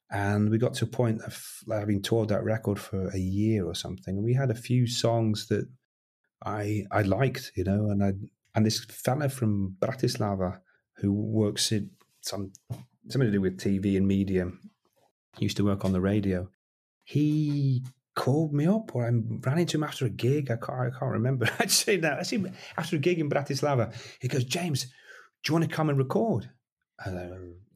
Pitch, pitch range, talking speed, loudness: 110 Hz, 100-130 Hz, 195 wpm, -28 LUFS